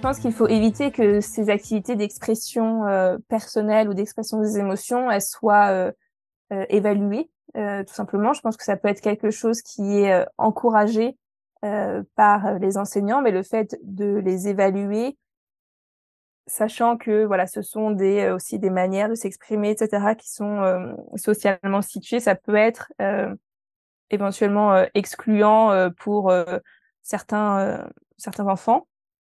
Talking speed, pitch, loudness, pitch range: 155 wpm, 210 Hz, -22 LUFS, 200-220 Hz